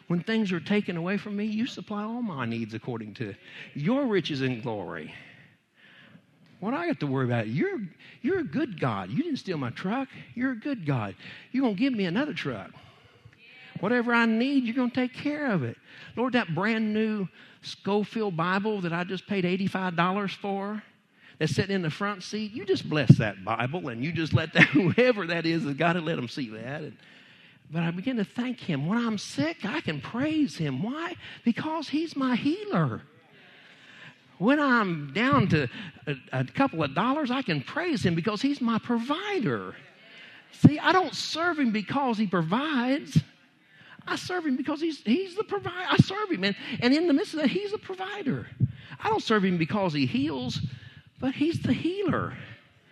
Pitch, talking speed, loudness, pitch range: 210 Hz, 195 wpm, -27 LUFS, 160-260 Hz